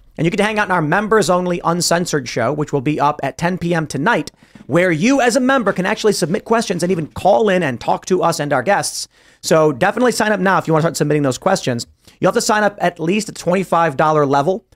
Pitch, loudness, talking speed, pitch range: 175 Hz, -16 LUFS, 250 wpm, 155-200 Hz